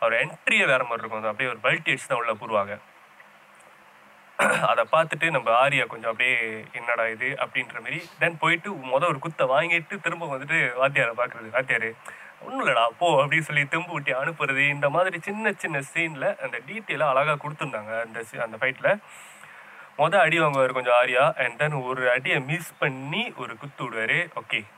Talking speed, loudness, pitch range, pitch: 165 wpm, -24 LUFS, 125-165 Hz, 145 Hz